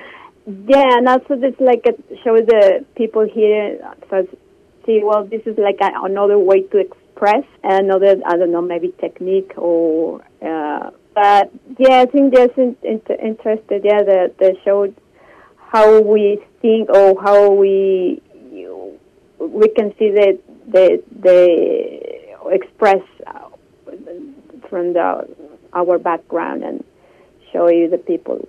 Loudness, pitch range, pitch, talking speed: -14 LUFS, 190-245 Hz, 210 Hz, 135 wpm